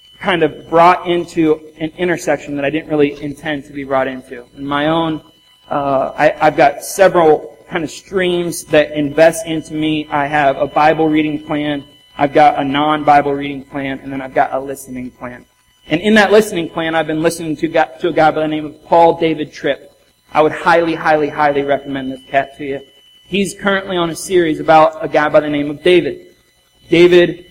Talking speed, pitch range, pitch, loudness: 200 wpm, 145-165 Hz, 155 Hz, -14 LUFS